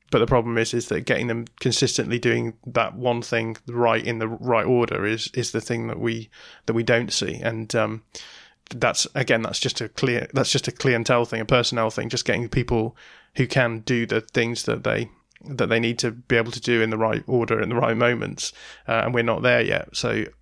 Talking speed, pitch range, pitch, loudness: 225 wpm, 115-125 Hz, 120 Hz, -23 LUFS